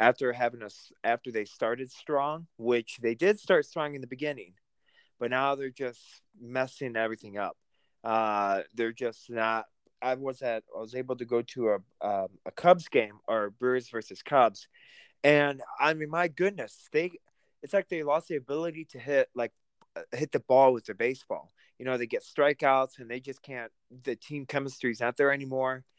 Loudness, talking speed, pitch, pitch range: -30 LUFS, 185 wpm, 130 Hz, 120-145 Hz